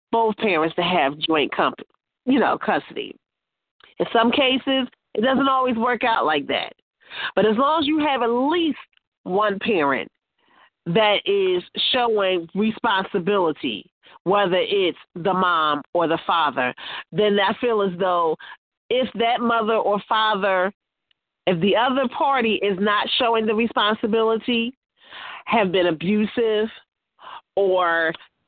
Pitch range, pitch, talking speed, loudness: 190-245 Hz, 220 Hz, 135 wpm, -21 LUFS